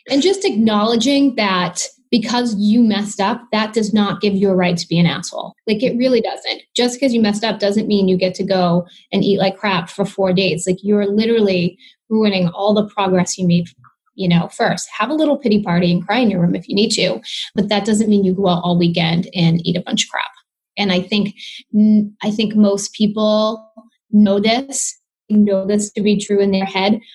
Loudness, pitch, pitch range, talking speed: -16 LUFS, 205 Hz, 190-220 Hz, 220 wpm